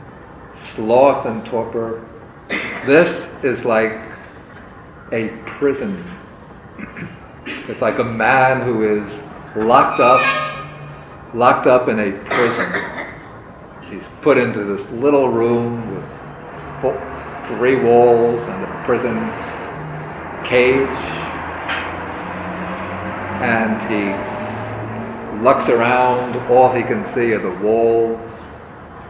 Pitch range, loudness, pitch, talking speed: 110-125 Hz, -17 LUFS, 115 Hz, 95 wpm